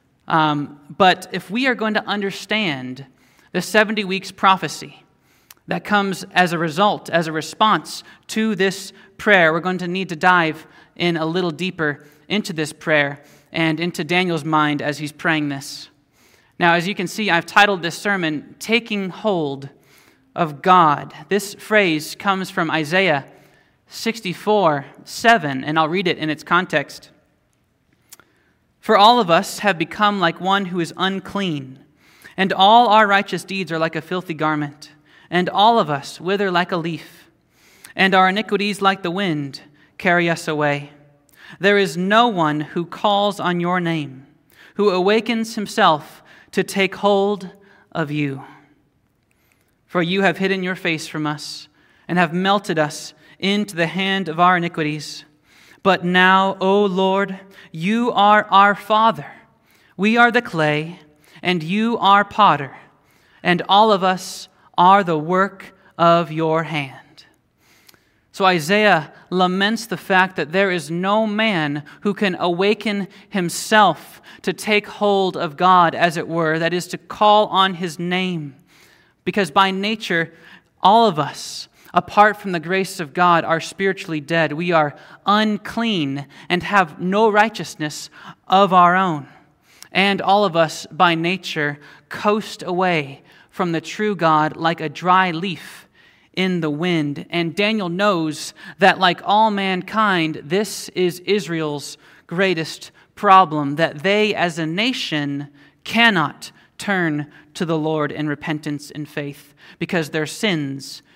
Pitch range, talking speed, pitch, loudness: 155-195 Hz, 145 wpm, 180 Hz, -18 LUFS